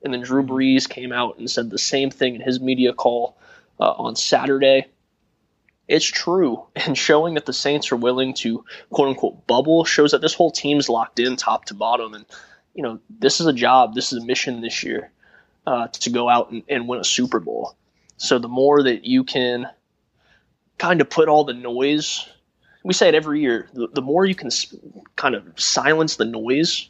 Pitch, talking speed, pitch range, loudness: 130 Hz, 205 wpm, 125-150 Hz, -19 LUFS